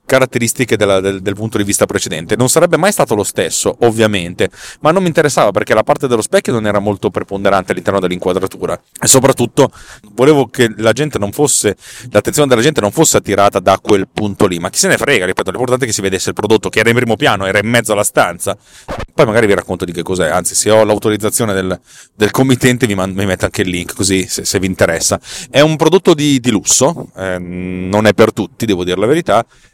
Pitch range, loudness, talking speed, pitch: 95-130 Hz, -13 LUFS, 225 wpm, 105 Hz